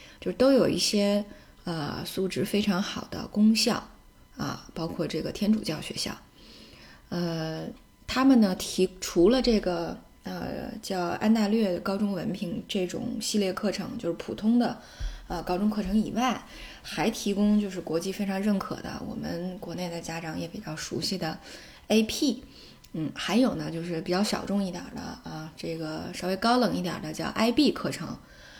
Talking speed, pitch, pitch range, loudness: 245 characters per minute, 205 Hz, 180-225 Hz, -28 LUFS